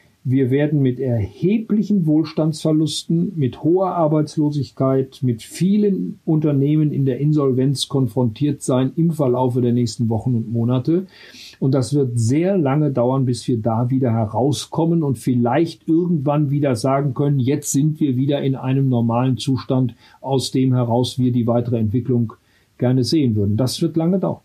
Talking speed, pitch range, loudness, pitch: 150 wpm, 125-155 Hz, -19 LUFS, 135 Hz